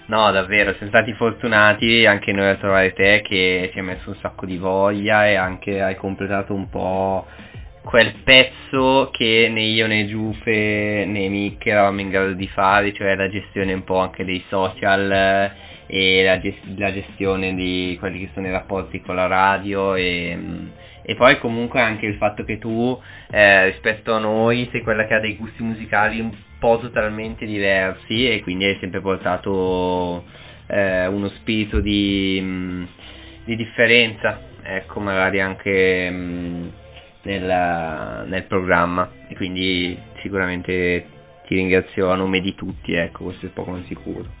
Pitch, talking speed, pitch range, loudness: 95 Hz, 155 wpm, 95-105 Hz, -19 LUFS